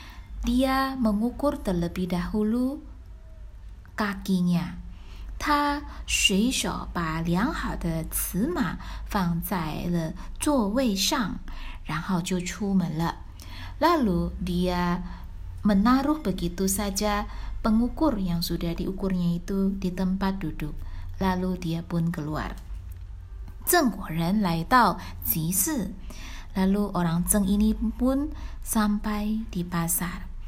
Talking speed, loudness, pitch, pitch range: 55 wpm, -26 LUFS, 185 Hz, 170-215 Hz